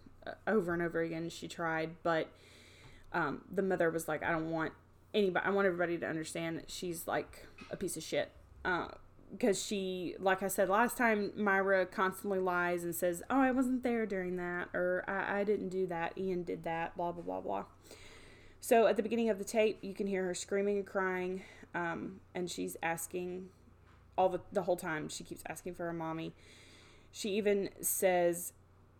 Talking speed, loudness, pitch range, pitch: 190 wpm, -35 LUFS, 165-195 Hz, 180 Hz